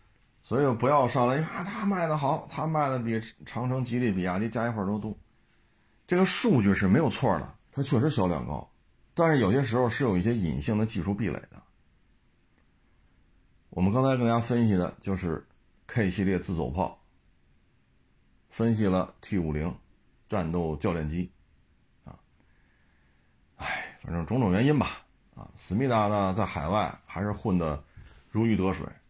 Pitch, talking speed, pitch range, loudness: 100 Hz, 240 characters per minute, 80-120 Hz, -28 LUFS